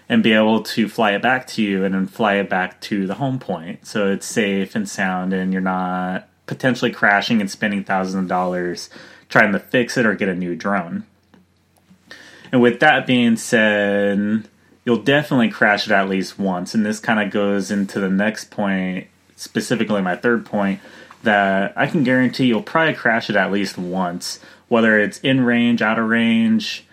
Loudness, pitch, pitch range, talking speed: -18 LUFS, 100 Hz, 95-115 Hz, 190 wpm